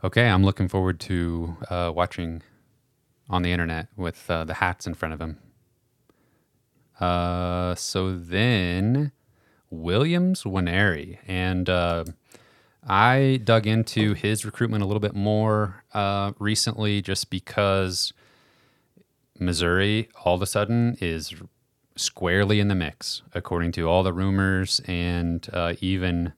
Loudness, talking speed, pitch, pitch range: -24 LUFS, 125 wpm, 95 Hz, 90-110 Hz